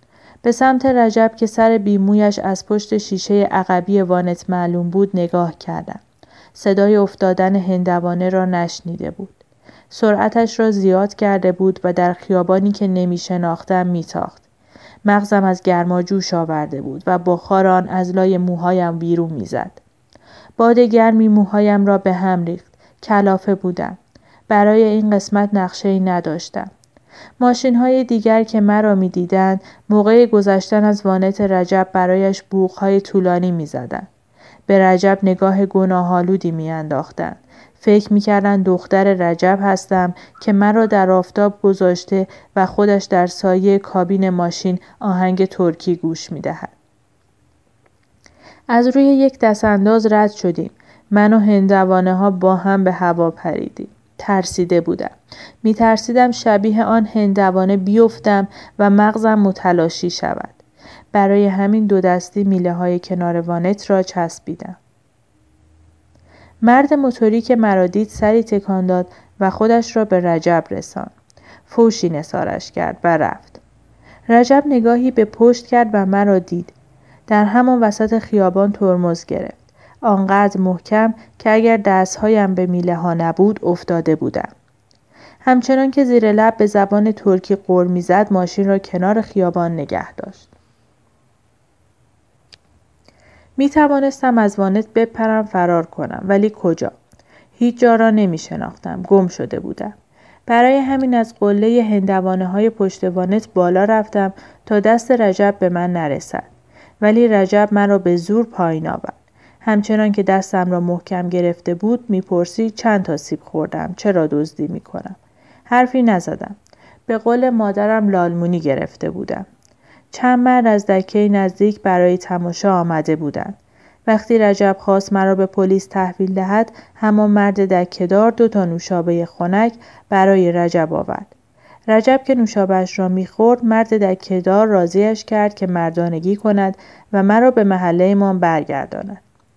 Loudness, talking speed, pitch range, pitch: -15 LUFS, 135 wpm, 180-215 Hz, 195 Hz